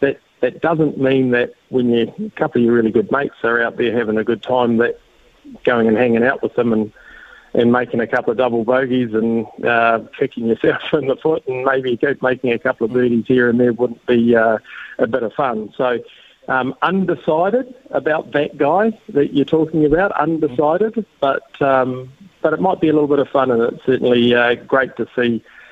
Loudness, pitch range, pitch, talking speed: -17 LUFS, 120-155 Hz, 130 Hz, 205 wpm